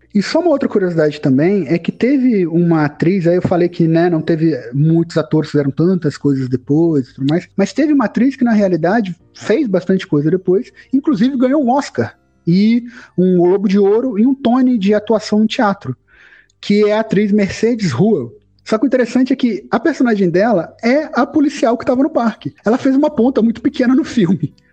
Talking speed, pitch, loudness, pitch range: 200 wpm, 205 Hz, -14 LUFS, 170-250 Hz